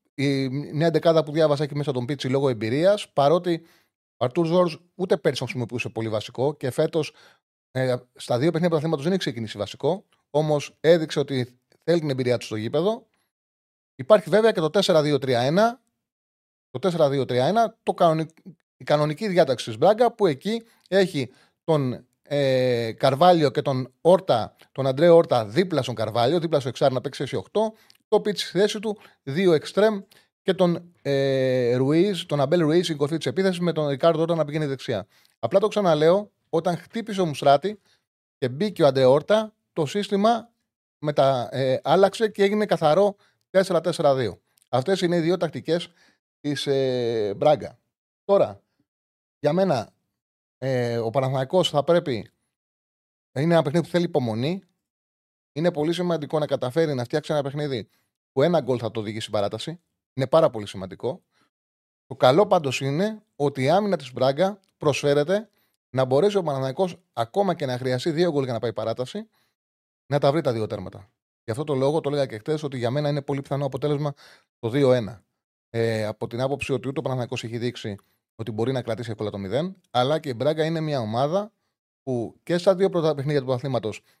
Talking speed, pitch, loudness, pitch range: 170 wpm, 145 Hz, -23 LUFS, 125-175 Hz